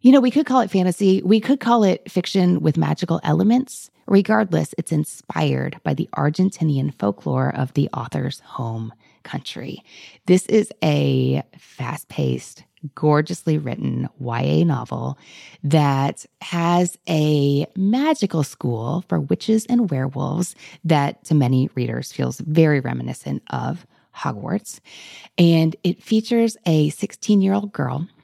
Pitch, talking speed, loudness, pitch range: 160 Hz, 130 wpm, -20 LUFS, 140-195 Hz